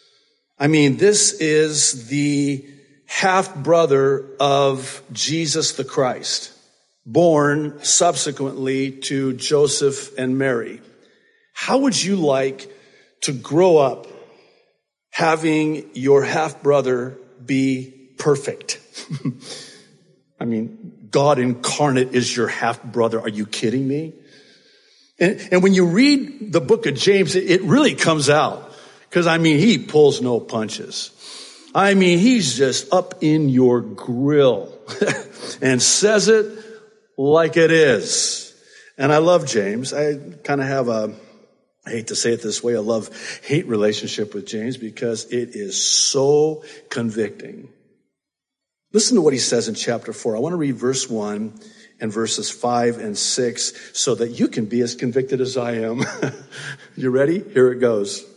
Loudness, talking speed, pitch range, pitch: -18 LUFS, 140 wpm, 125-185 Hz, 145 Hz